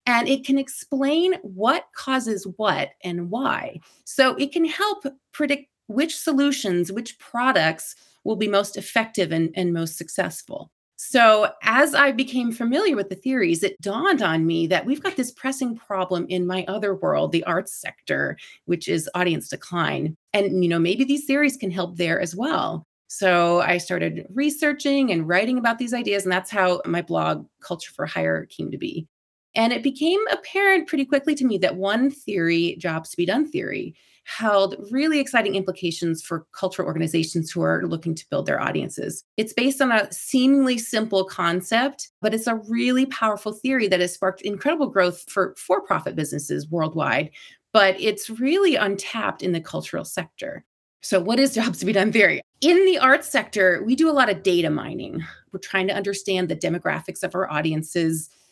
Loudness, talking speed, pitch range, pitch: -22 LUFS, 180 wpm, 180-270 Hz, 210 Hz